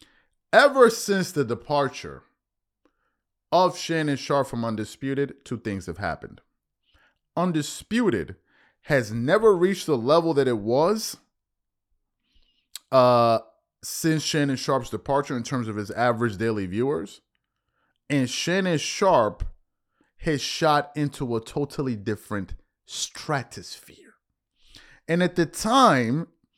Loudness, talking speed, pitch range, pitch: -24 LUFS, 110 wpm, 115-160 Hz, 140 Hz